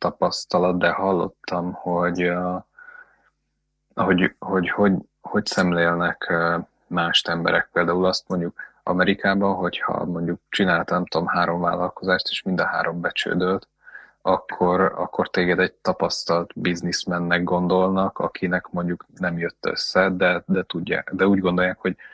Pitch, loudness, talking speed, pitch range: 90 Hz, -22 LUFS, 120 wpm, 85-95 Hz